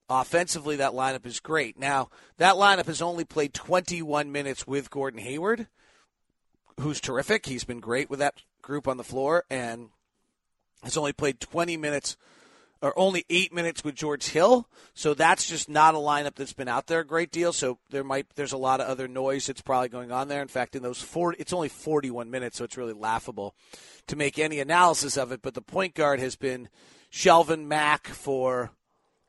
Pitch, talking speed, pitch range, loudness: 140 Hz, 195 wpm, 130-160 Hz, -26 LUFS